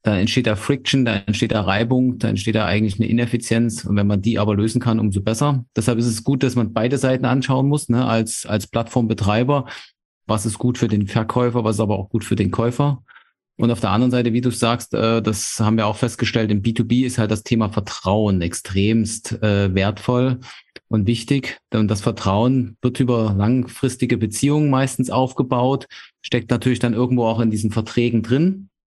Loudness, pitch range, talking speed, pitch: -19 LUFS, 110-125 Hz, 195 wpm, 115 Hz